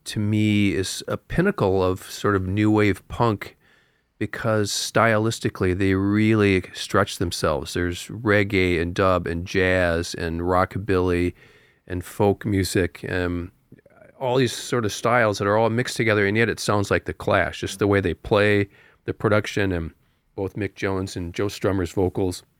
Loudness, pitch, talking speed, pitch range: -22 LUFS, 100 Hz, 160 wpm, 90-105 Hz